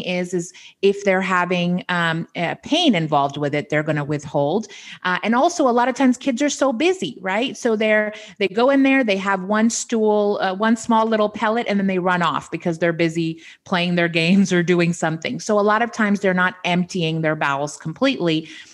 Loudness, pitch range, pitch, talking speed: -19 LUFS, 170-220 Hz, 190 Hz, 215 wpm